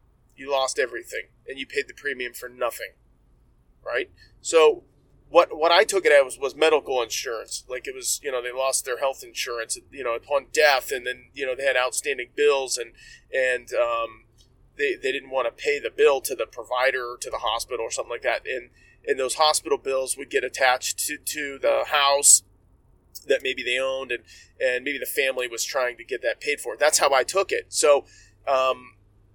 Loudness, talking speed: -23 LUFS, 205 wpm